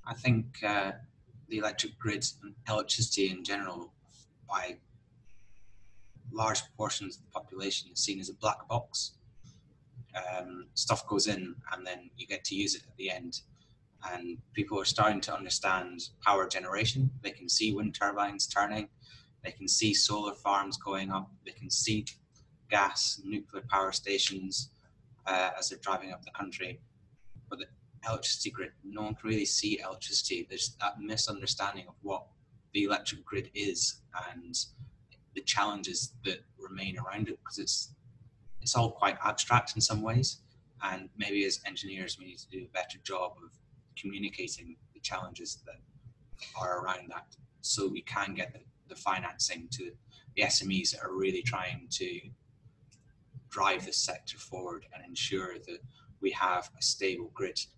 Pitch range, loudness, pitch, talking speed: 100-125 Hz, -33 LUFS, 110 Hz, 160 wpm